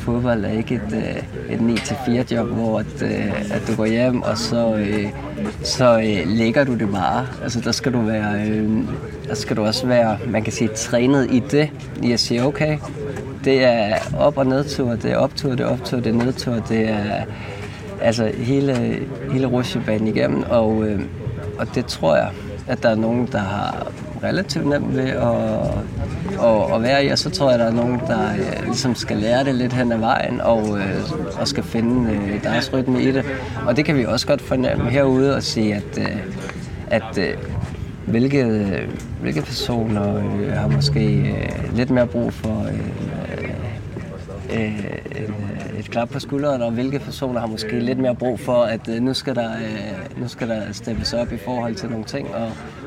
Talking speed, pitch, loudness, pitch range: 180 wpm, 115 Hz, -20 LUFS, 110-125 Hz